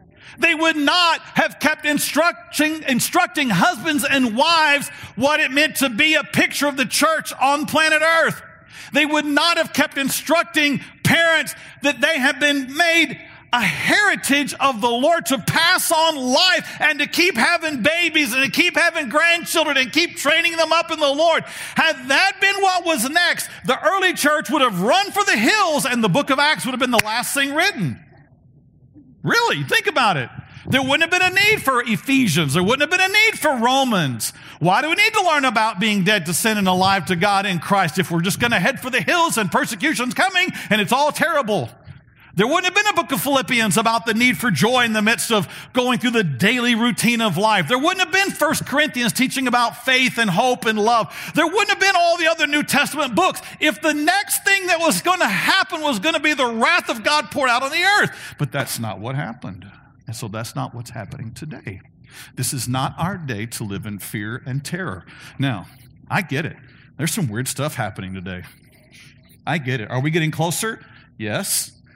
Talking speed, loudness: 210 wpm, -17 LUFS